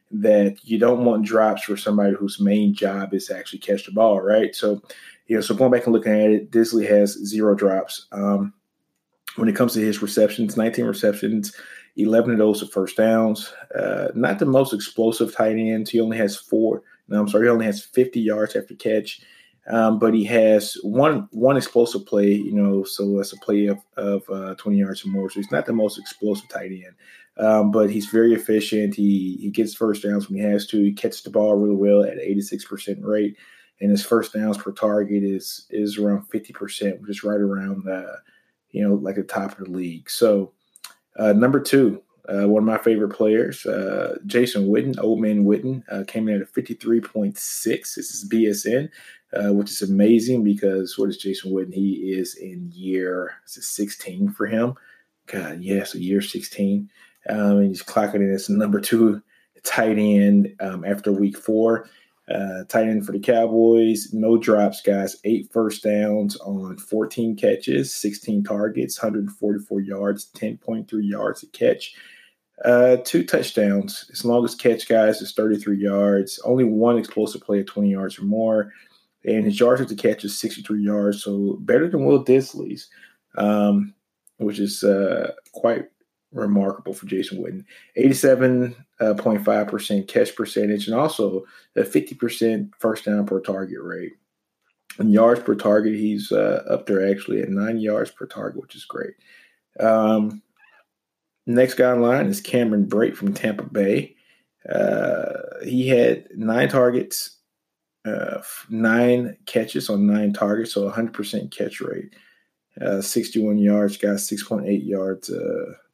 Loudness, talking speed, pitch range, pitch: -21 LUFS, 180 wpm, 100-110 Hz, 105 Hz